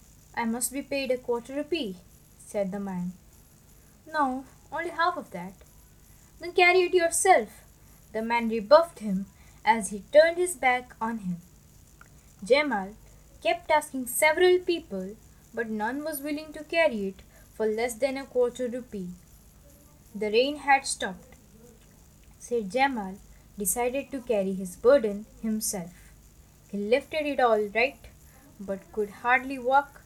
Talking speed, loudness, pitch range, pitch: 140 wpm, -27 LUFS, 205-295 Hz, 245 Hz